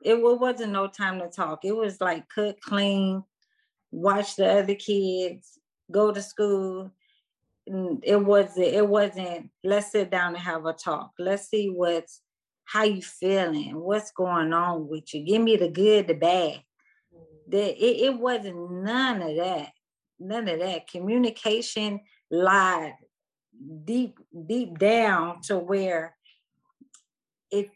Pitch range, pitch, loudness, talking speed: 175-215 Hz, 195 Hz, -25 LUFS, 135 wpm